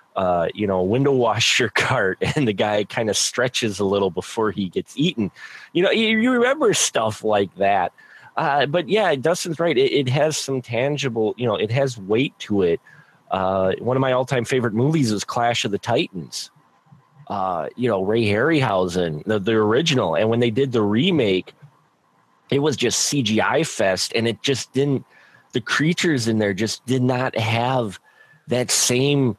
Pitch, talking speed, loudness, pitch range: 120 Hz, 180 wpm, -20 LUFS, 105-140 Hz